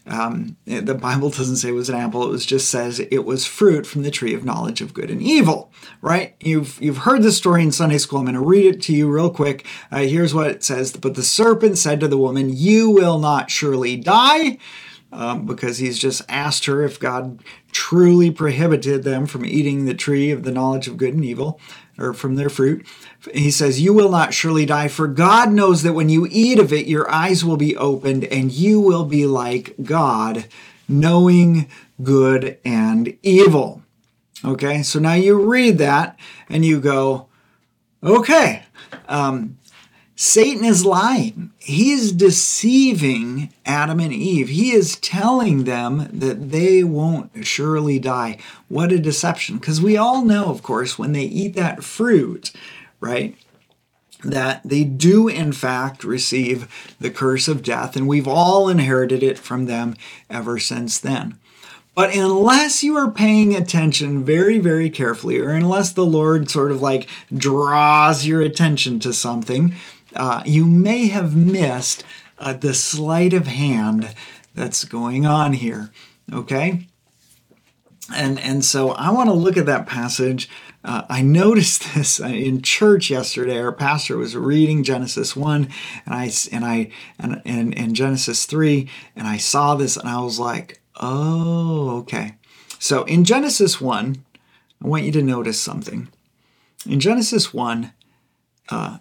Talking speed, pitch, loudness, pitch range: 165 wpm, 145 Hz, -17 LUFS, 130-175 Hz